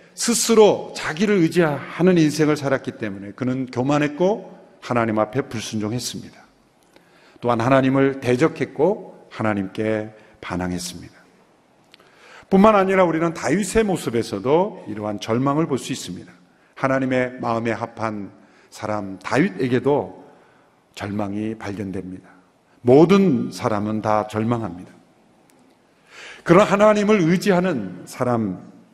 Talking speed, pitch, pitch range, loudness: 275 characters per minute, 125 Hz, 105-165 Hz, -20 LUFS